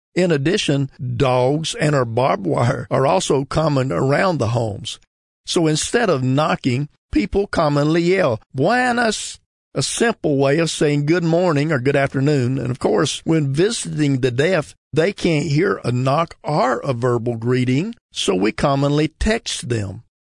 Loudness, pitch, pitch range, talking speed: -19 LUFS, 145 Hz, 130-165 Hz, 155 wpm